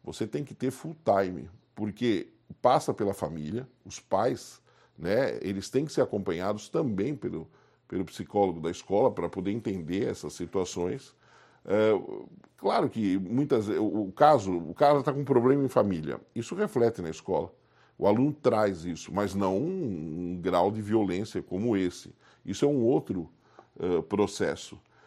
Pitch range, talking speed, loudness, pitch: 90-125 Hz, 155 wpm, -29 LUFS, 100 Hz